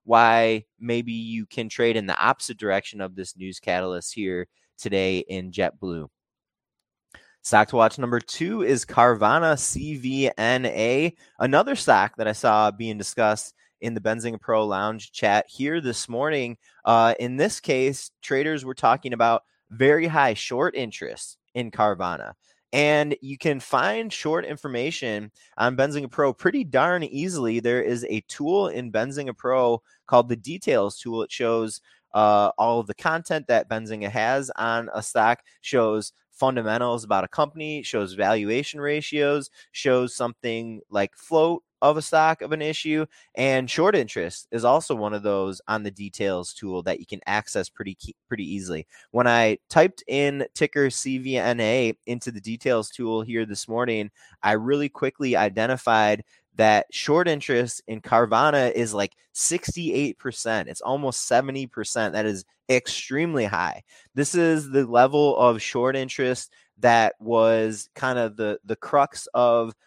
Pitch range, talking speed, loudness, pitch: 110-135 Hz, 150 wpm, -23 LUFS, 120 Hz